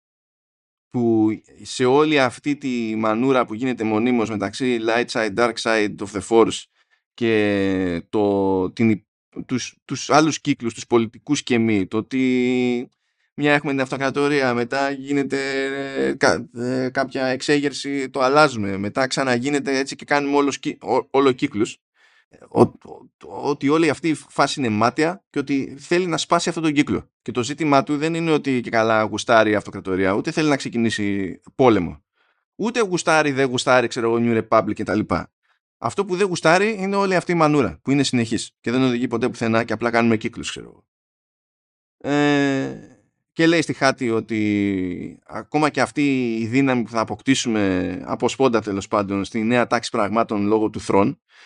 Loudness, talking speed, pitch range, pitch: -20 LUFS, 165 wpm, 110-140 Hz, 125 Hz